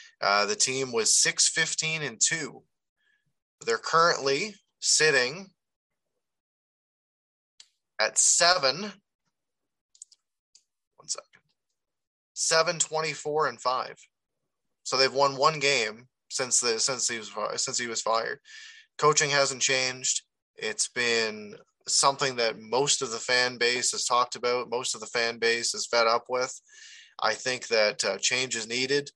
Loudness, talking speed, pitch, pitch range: -25 LUFS, 135 wpm, 140 Hz, 125-195 Hz